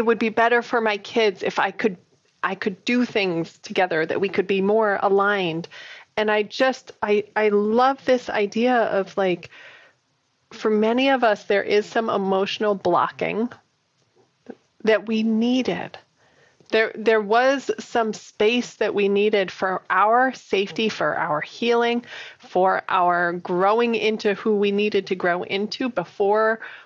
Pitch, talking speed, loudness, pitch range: 215 Hz, 150 wpm, -21 LUFS, 200-230 Hz